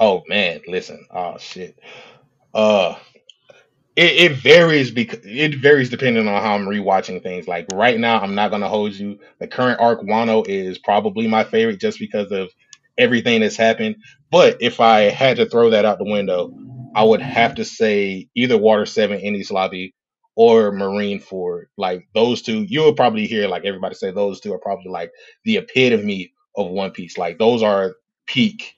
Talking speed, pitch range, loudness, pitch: 180 wpm, 100-150 Hz, -17 LUFS, 115 Hz